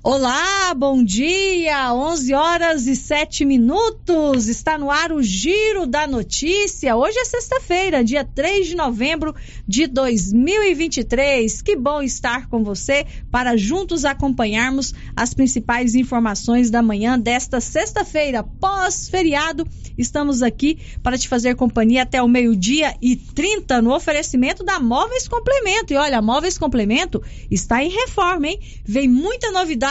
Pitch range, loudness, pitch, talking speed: 245-340 Hz, -18 LUFS, 280 Hz, 135 wpm